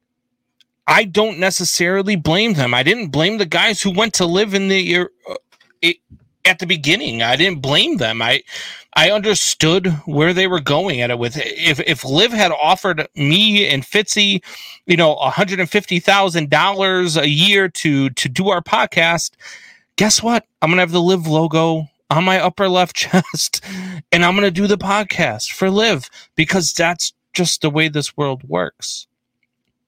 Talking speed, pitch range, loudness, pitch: 175 wpm, 160-200 Hz, -15 LUFS, 180 Hz